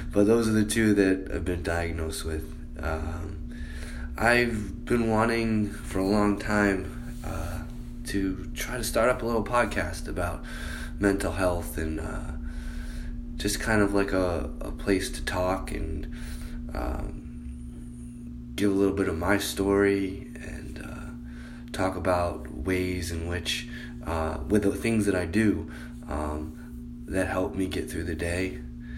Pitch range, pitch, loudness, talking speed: 60-100 Hz, 80 Hz, -28 LUFS, 150 wpm